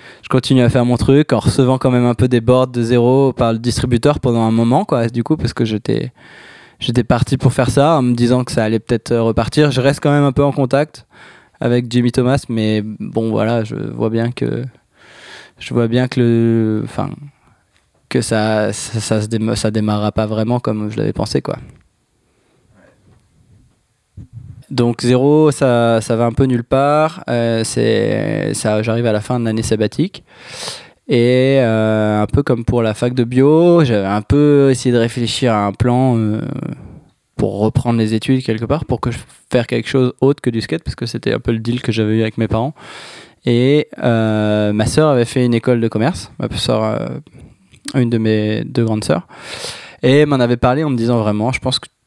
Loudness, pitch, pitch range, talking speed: -15 LUFS, 120 Hz, 110-130 Hz, 195 wpm